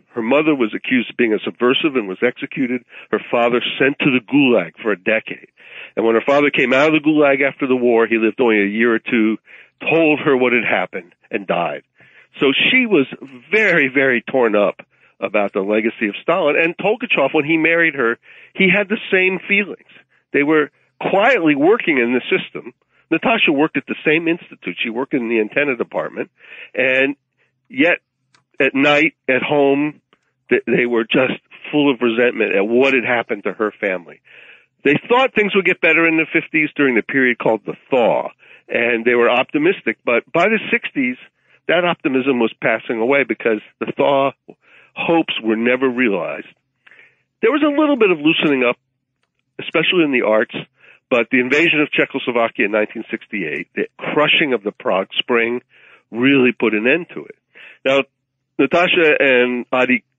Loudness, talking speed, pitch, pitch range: -16 LUFS, 175 wpm, 135 Hz, 120-165 Hz